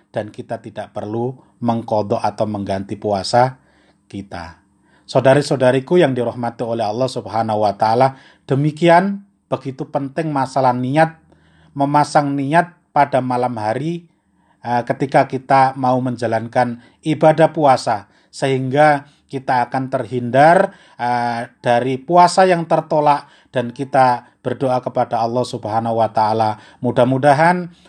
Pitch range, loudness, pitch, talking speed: 115-145 Hz, -17 LUFS, 130 Hz, 110 wpm